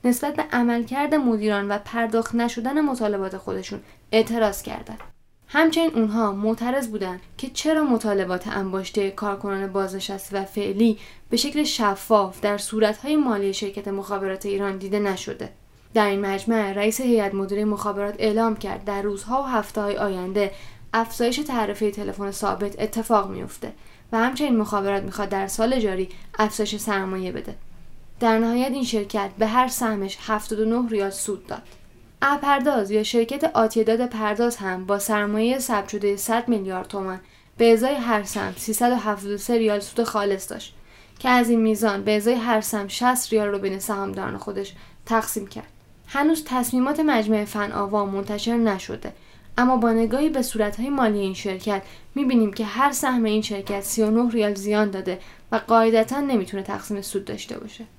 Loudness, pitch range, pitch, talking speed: -23 LUFS, 200-235 Hz, 215 Hz, 150 wpm